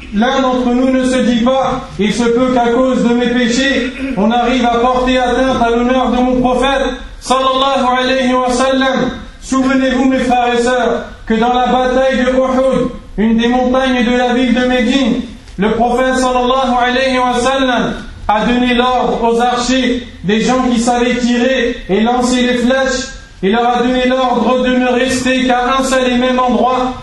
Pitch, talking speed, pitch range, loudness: 250 Hz, 170 wpm, 240-255 Hz, -12 LUFS